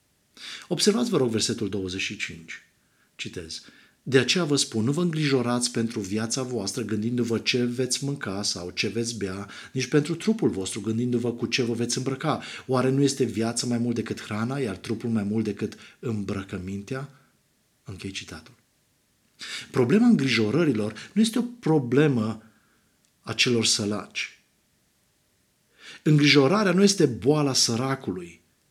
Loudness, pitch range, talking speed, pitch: -25 LUFS, 110-140 Hz, 130 wpm, 120 Hz